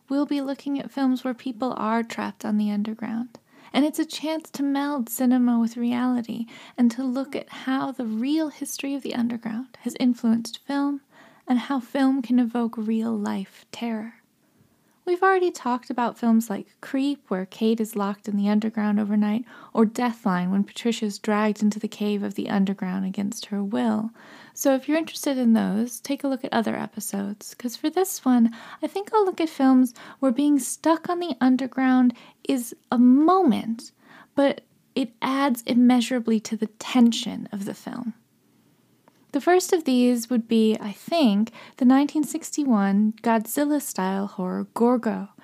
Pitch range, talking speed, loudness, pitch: 220-275 Hz, 170 wpm, -24 LUFS, 245 Hz